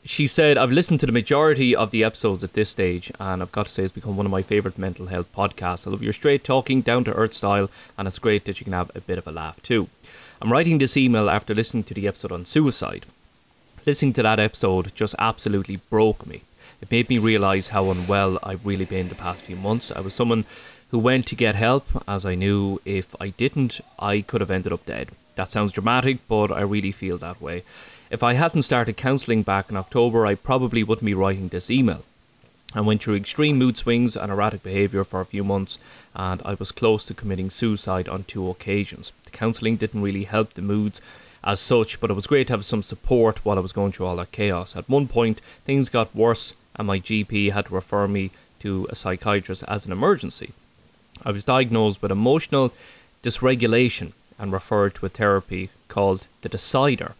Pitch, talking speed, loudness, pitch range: 105 Hz, 215 wpm, -23 LUFS, 95-115 Hz